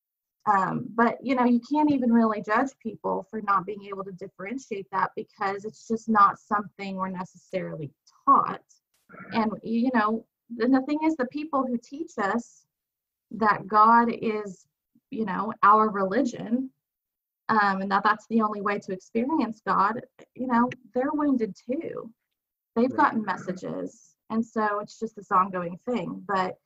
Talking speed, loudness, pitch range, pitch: 160 wpm, -26 LUFS, 195-245 Hz, 220 Hz